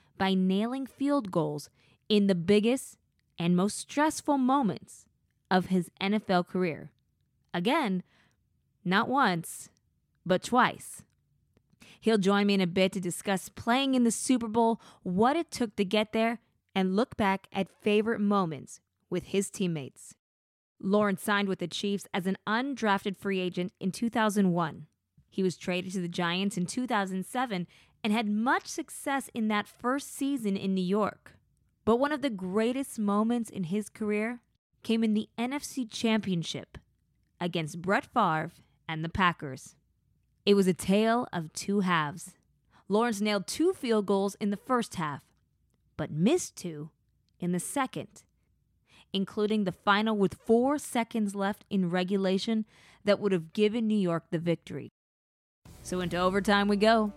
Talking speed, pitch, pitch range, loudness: 150 wpm, 200 Hz, 180-225 Hz, -29 LUFS